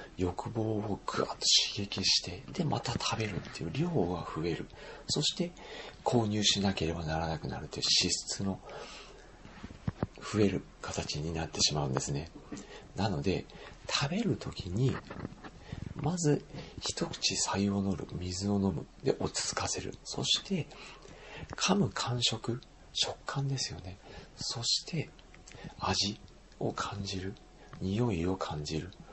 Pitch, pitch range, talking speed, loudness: 100 Hz, 90-120 Hz, 245 characters per minute, -32 LUFS